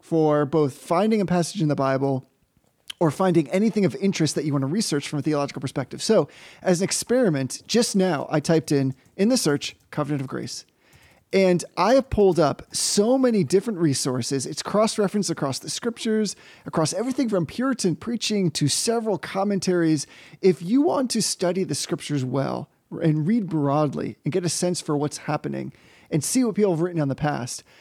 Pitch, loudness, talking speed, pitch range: 170 Hz, -23 LUFS, 185 wpm, 145-205 Hz